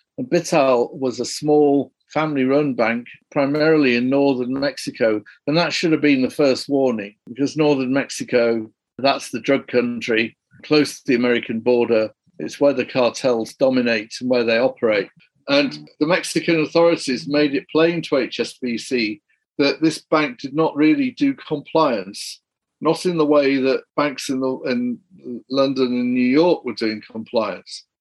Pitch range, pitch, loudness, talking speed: 120-150 Hz, 135 Hz, -19 LUFS, 160 wpm